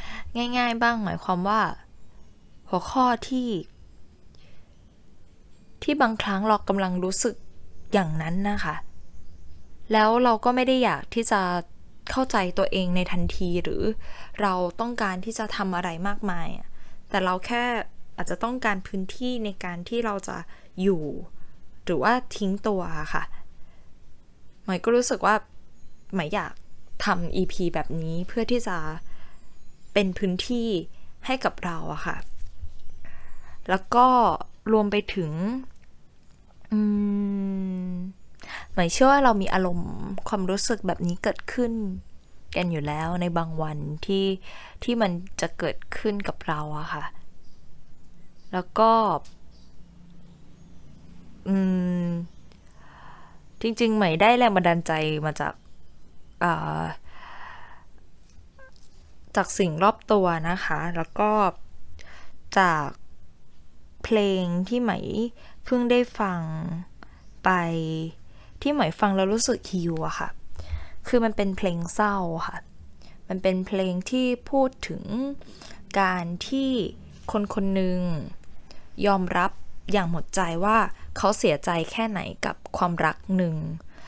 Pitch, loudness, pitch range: 185 Hz, -25 LUFS, 145-215 Hz